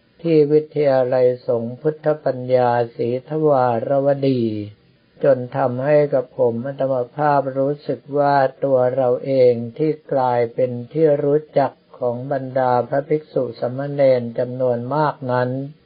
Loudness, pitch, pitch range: -19 LUFS, 135 Hz, 125-145 Hz